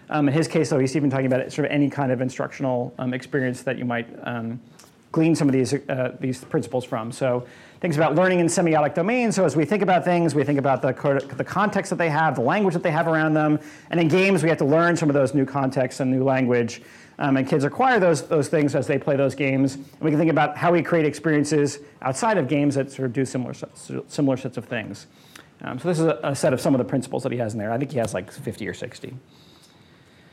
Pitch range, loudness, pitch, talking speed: 130-160 Hz, -22 LUFS, 140 Hz, 260 wpm